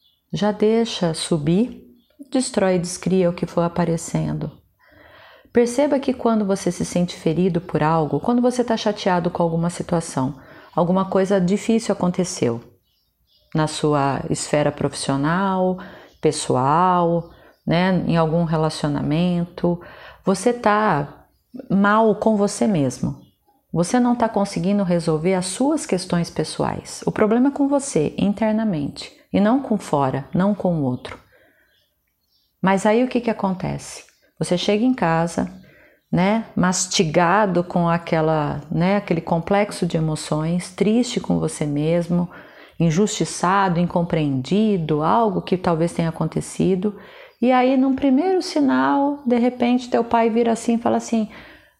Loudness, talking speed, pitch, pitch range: -20 LUFS, 130 wpm, 185 Hz, 165-220 Hz